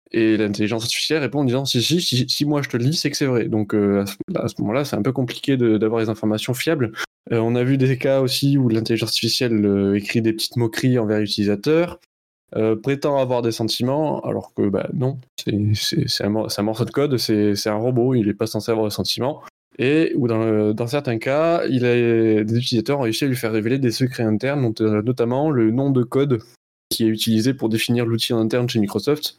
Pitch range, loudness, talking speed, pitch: 110-130 Hz, -20 LUFS, 235 wpm, 115 Hz